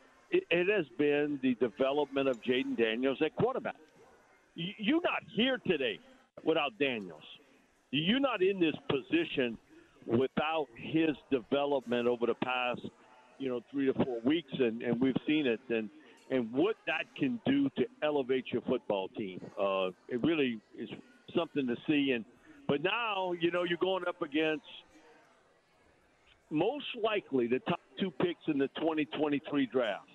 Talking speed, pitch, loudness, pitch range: 155 wpm, 150 Hz, -33 LUFS, 130-195 Hz